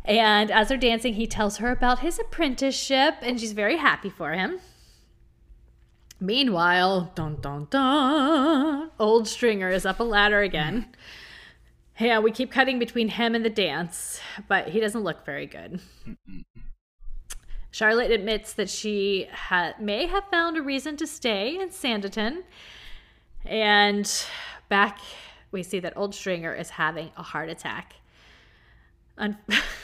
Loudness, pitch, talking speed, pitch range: -24 LUFS, 220 Hz, 140 wpm, 200-255 Hz